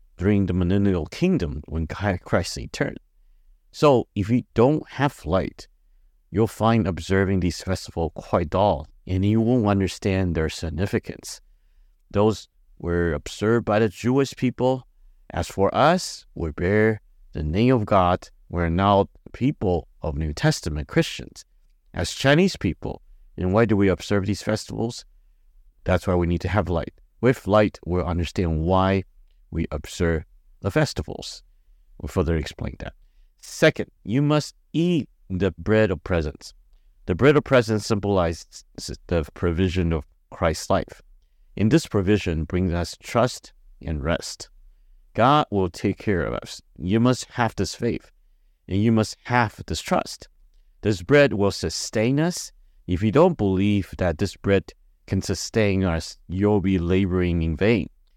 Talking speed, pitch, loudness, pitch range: 145 wpm, 95 Hz, -23 LUFS, 85-110 Hz